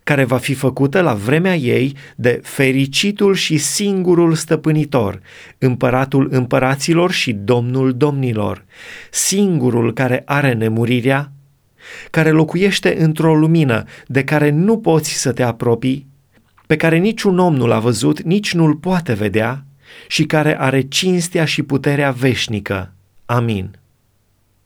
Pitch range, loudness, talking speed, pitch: 125-160 Hz, -16 LUFS, 125 wpm, 135 Hz